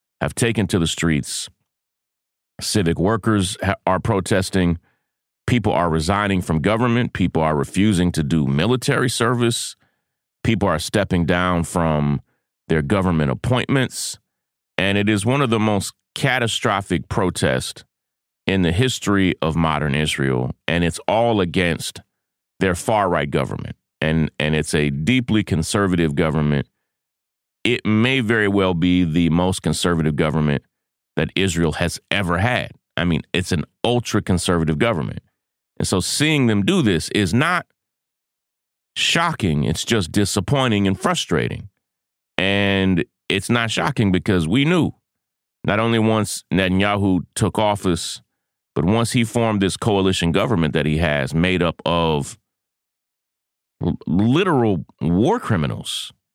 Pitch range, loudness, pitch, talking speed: 80-110 Hz, -19 LUFS, 95 Hz, 130 wpm